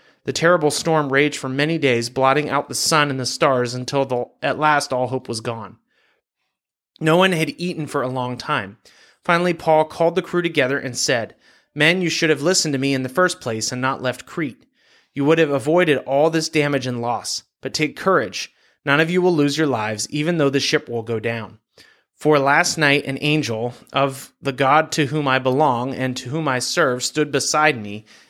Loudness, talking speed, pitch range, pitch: -19 LUFS, 210 wpm, 130-155 Hz, 140 Hz